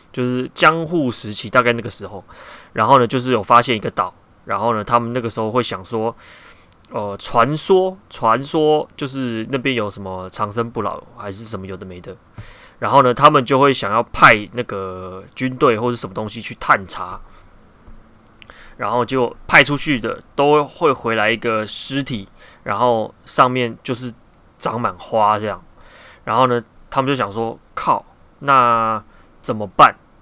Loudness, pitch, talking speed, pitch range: -17 LUFS, 120 Hz, 240 characters per minute, 105-130 Hz